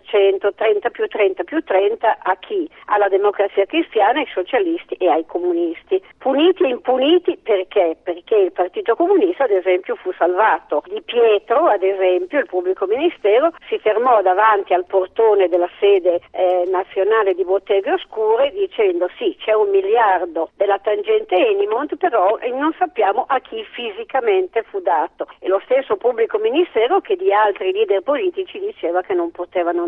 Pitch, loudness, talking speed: 220 Hz, -18 LUFS, 155 wpm